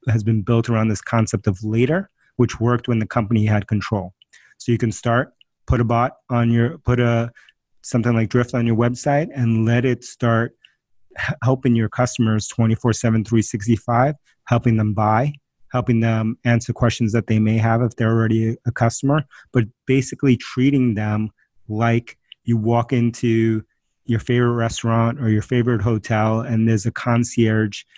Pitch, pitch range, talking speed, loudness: 115 Hz, 115-125 Hz, 165 wpm, -20 LUFS